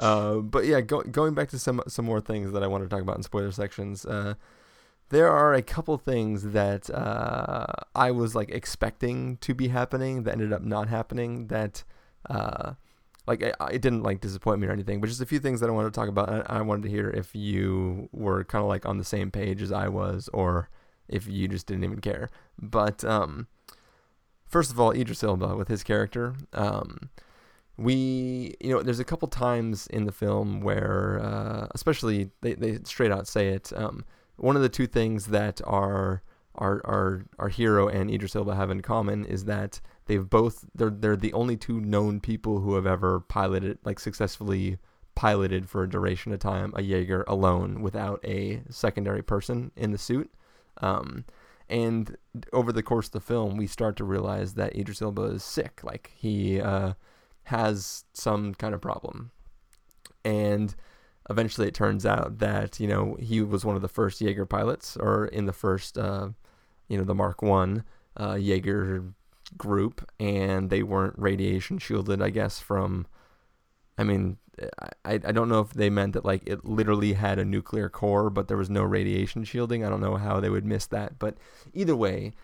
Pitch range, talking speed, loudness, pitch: 100-110 Hz, 195 wpm, -28 LUFS, 105 Hz